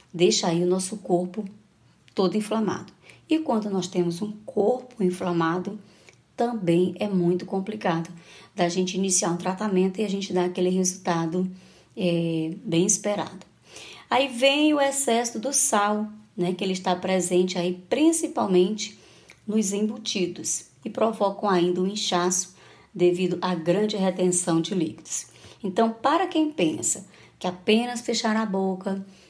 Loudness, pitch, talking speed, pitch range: -24 LUFS, 190 Hz, 140 wpm, 180-215 Hz